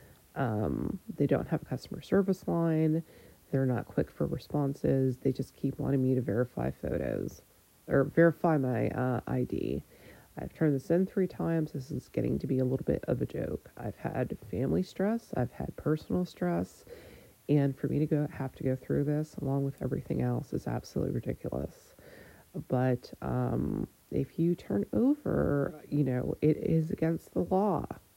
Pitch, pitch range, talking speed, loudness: 145 Hz, 130-165 Hz, 175 wpm, -32 LUFS